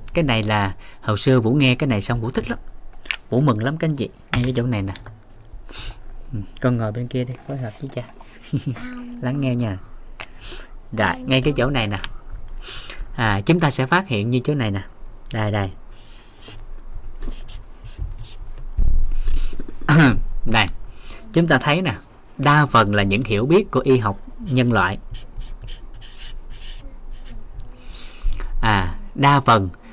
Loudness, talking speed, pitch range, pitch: -20 LUFS, 145 wpm, 105-130 Hz, 115 Hz